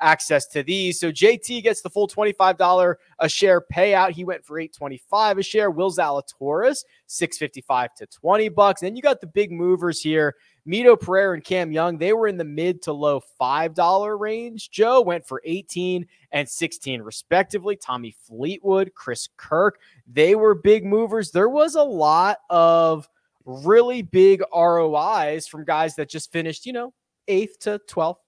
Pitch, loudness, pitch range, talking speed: 180 Hz, -20 LUFS, 155-205 Hz, 165 wpm